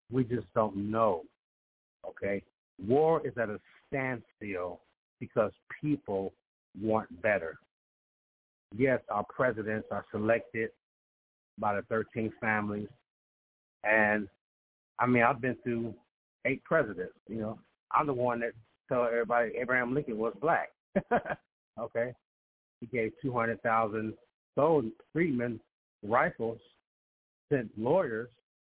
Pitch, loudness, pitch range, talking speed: 110 Hz, -32 LUFS, 100-120 Hz, 110 wpm